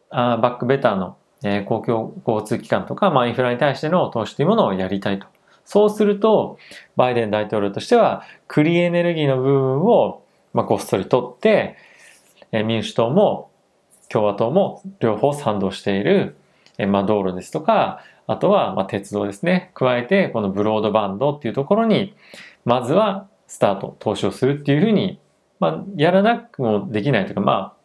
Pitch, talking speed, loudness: 130 Hz, 350 characters per minute, -19 LUFS